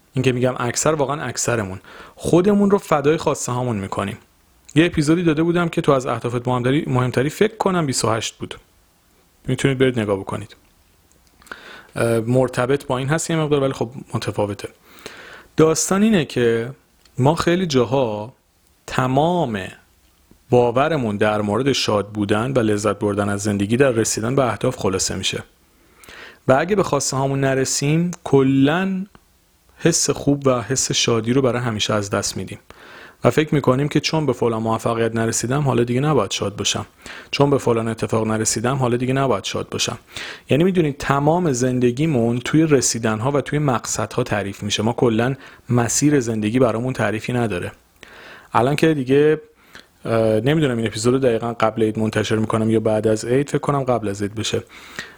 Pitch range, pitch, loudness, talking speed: 110-140 Hz, 125 Hz, -19 LUFS, 155 wpm